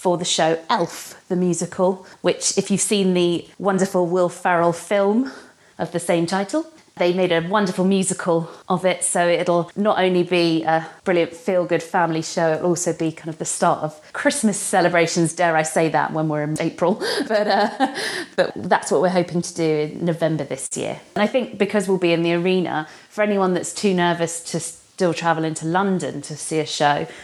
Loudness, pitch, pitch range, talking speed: -20 LUFS, 175 Hz, 165-190 Hz, 200 wpm